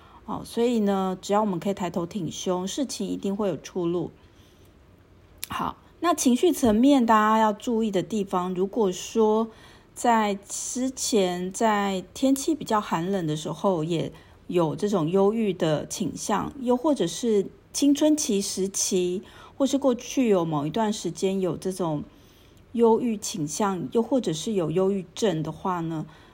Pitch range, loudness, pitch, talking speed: 180-230 Hz, -25 LUFS, 200 Hz, 225 characters per minute